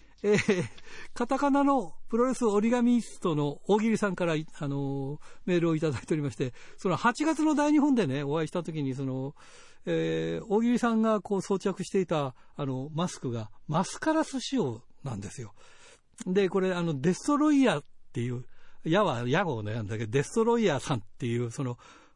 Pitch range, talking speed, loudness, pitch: 140-225 Hz, 365 characters per minute, -29 LUFS, 180 Hz